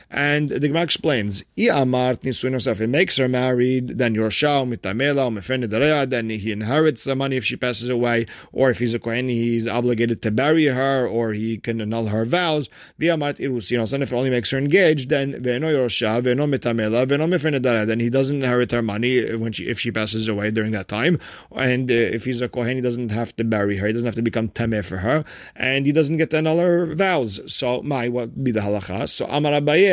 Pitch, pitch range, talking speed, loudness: 125 Hz, 115-140 Hz, 185 wpm, -21 LUFS